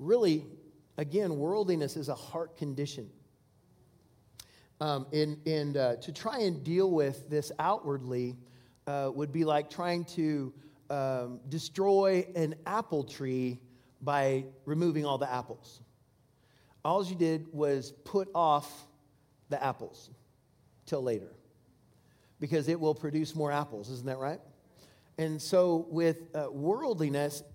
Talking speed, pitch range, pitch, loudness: 125 wpm, 130-160 Hz, 145 Hz, -32 LUFS